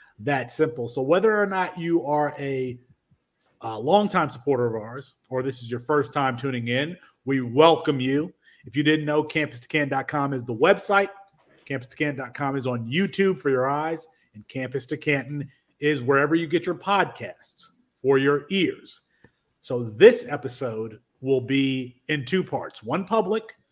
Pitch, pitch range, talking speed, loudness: 145 Hz, 130-165 Hz, 155 wpm, -24 LUFS